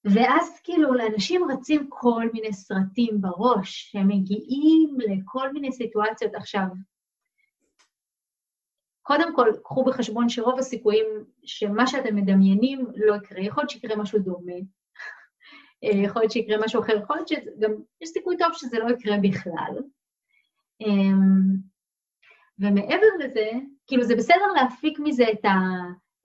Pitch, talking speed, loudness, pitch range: 230 Hz, 125 wpm, -23 LUFS, 205-280 Hz